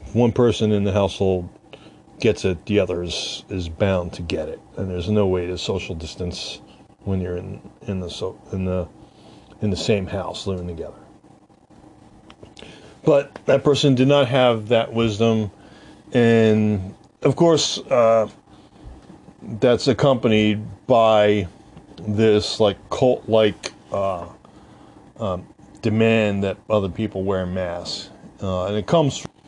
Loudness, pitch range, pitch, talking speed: -21 LUFS, 95-115 Hz, 105 Hz, 135 wpm